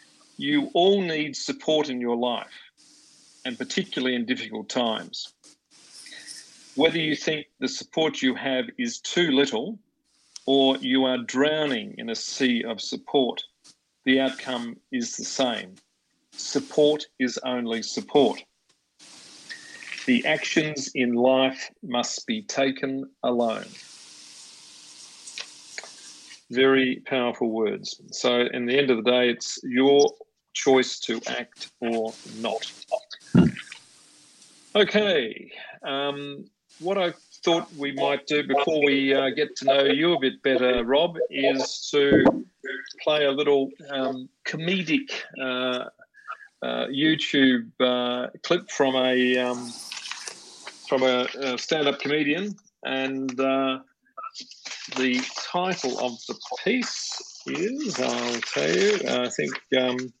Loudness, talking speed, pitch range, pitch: -24 LUFS, 115 wpm, 125-170 Hz, 135 Hz